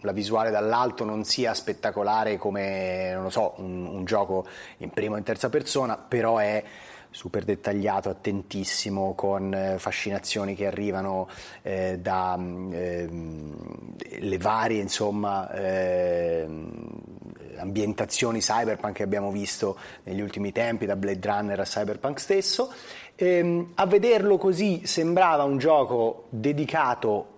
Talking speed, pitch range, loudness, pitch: 125 wpm, 95-115 Hz, -26 LUFS, 105 Hz